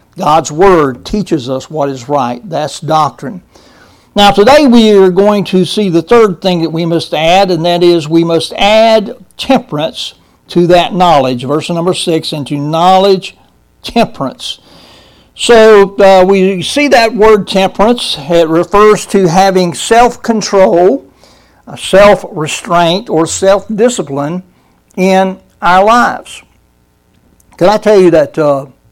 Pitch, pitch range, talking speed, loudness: 185 Hz, 160-205 Hz, 135 wpm, -9 LUFS